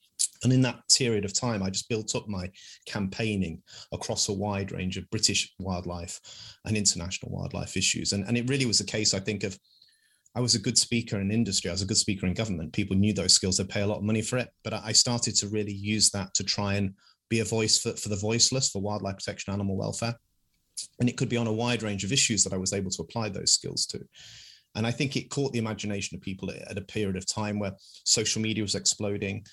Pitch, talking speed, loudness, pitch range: 105 Hz, 240 wpm, -27 LUFS, 100-115 Hz